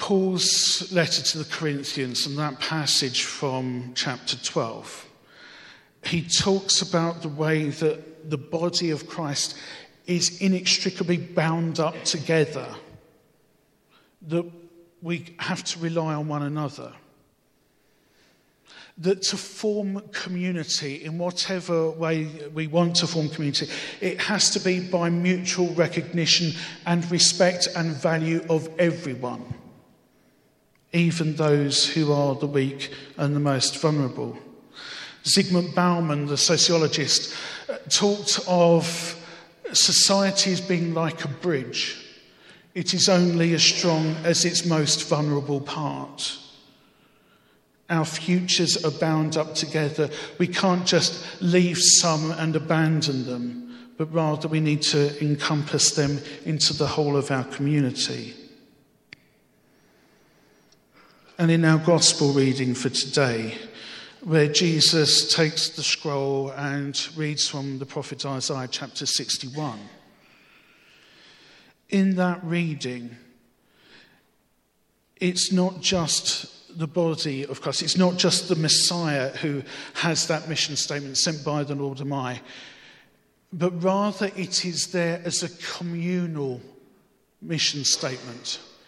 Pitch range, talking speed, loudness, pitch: 145-175 Hz, 115 wpm, -23 LUFS, 160 Hz